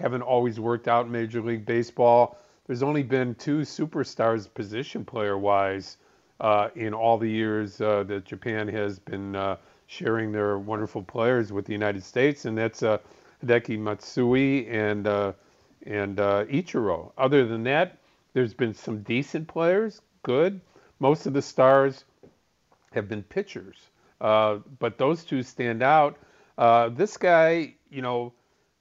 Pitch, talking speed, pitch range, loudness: 115 Hz, 150 wpm, 105-135 Hz, -25 LUFS